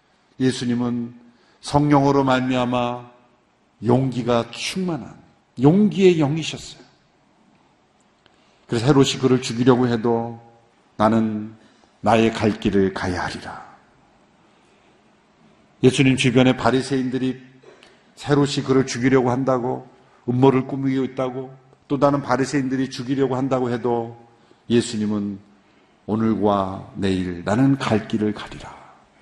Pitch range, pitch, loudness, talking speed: 115-135 Hz, 125 Hz, -20 LUFS, 245 characters per minute